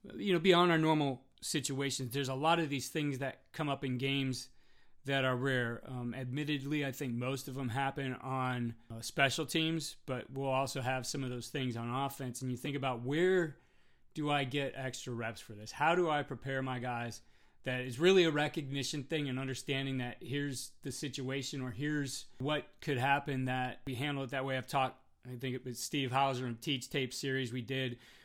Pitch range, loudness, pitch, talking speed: 125-145 Hz, -35 LUFS, 135 Hz, 205 wpm